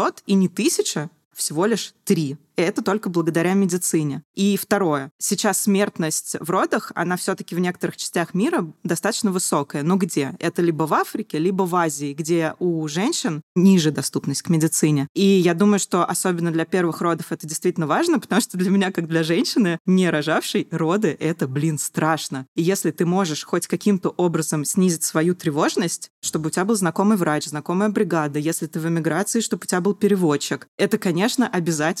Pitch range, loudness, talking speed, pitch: 160-195 Hz, -21 LUFS, 180 wpm, 175 Hz